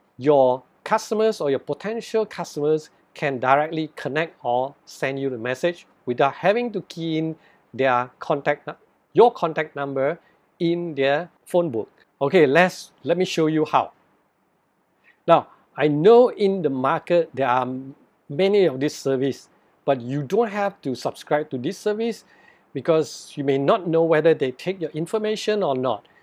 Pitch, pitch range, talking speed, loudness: 155 Hz, 135-185 Hz, 155 wpm, -22 LUFS